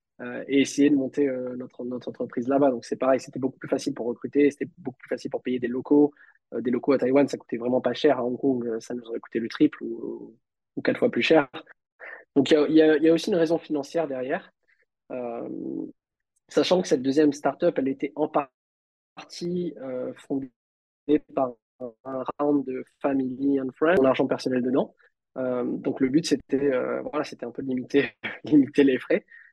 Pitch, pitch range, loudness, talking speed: 135 Hz, 125-145 Hz, -25 LUFS, 205 wpm